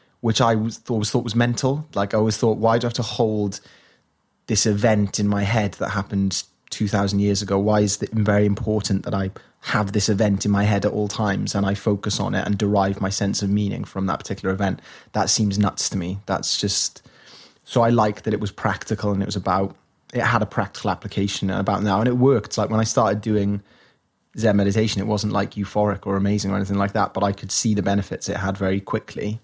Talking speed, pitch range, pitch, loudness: 230 wpm, 100-110 Hz, 105 Hz, -22 LUFS